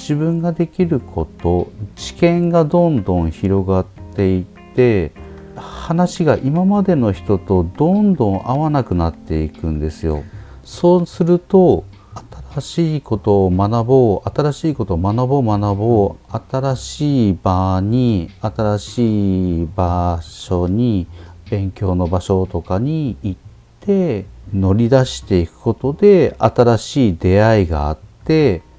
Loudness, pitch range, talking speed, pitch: -16 LUFS, 95-140 Hz, 240 characters per minute, 105 Hz